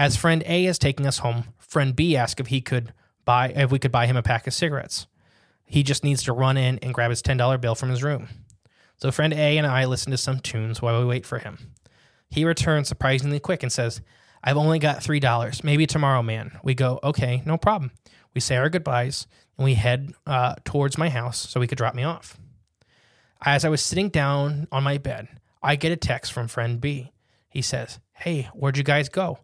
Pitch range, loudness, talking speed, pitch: 120-145 Hz, -23 LUFS, 225 wpm, 130 Hz